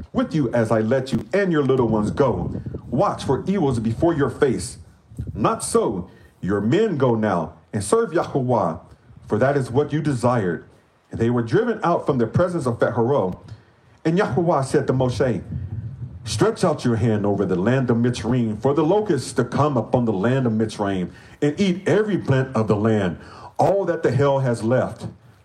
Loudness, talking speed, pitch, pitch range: -21 LUFS, 185 wpm, 125 Hz, 110-150 Hz